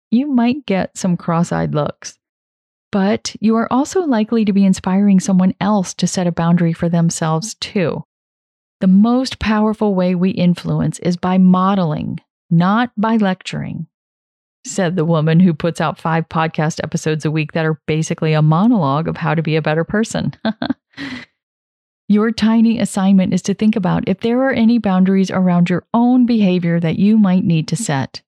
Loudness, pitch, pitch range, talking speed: -16 LUFS, 185 Hz, 170-215 Hz, 170 wpm